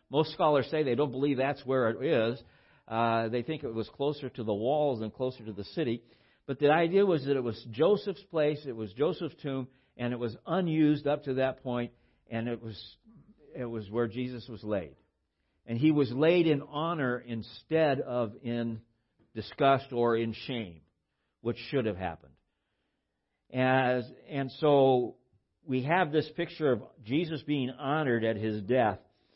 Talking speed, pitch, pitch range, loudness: 175 wpm, 125 Hz, 115-145 Hz, -30 LUFS